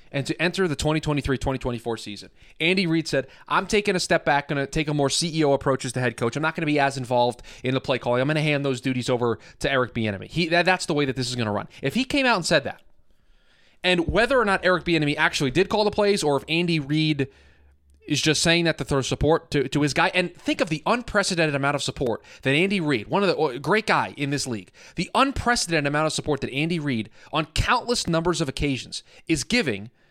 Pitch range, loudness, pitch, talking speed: 130-170 Hz, -23 LUFS, 150 Hz, 240 wpm